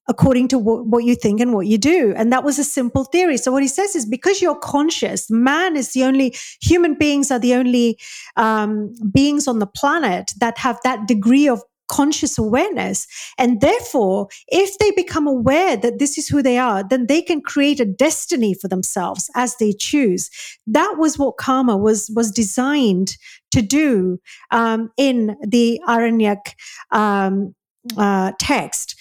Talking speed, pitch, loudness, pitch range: 175 wpm, 250 Hz, -17 LUFS, 225-285 Hz